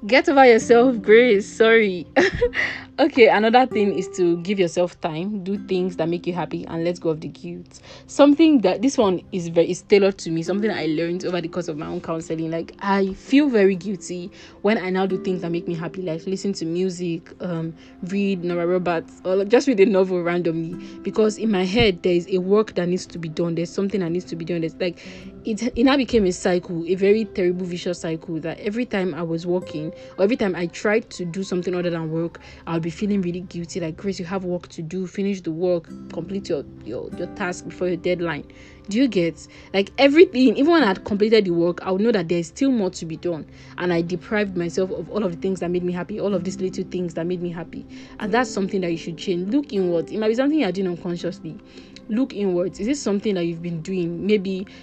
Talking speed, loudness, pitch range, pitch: 240 wpm, -21 LUFS, 170-205 Hz, 185 Hz